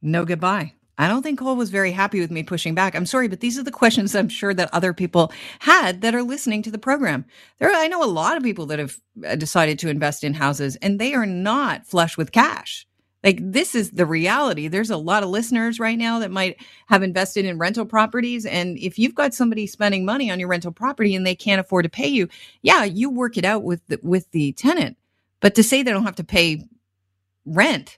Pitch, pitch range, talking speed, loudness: 195 Hz, 175-230 Hz, 235 wpm, -20 LUFS